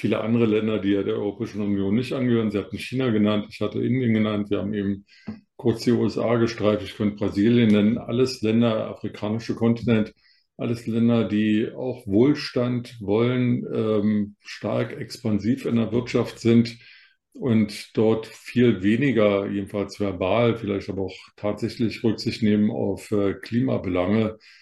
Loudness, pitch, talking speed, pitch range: -23 LUFS, 110 Hz, 150 wpm, 105-115 Hz